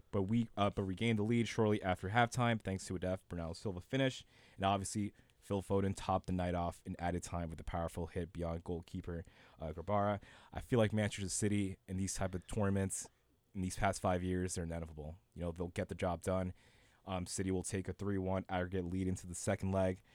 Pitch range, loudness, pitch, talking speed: 90-105 Hz, -38 LUFS, 95 Hz, 215 wpm